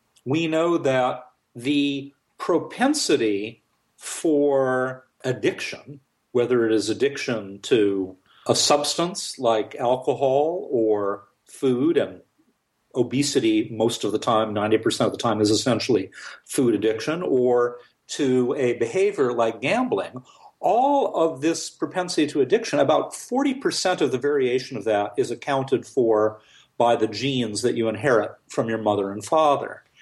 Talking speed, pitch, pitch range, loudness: 130 wpm, 130 Hz, 115-160 Hz, -23 LUFS